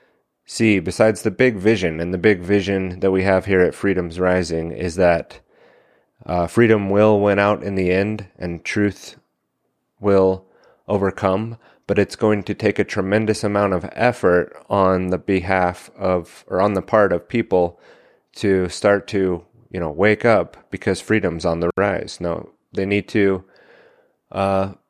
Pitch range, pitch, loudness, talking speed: 90-105 Hz, 95 Hz, -19 LUFS, 160 wpm